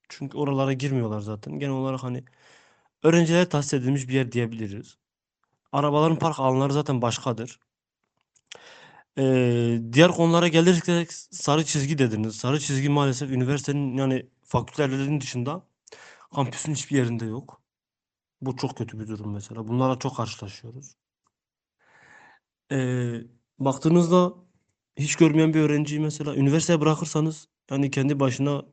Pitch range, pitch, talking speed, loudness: 125-155 Hz, 135 Hz, 120 wpm, -24 LUFS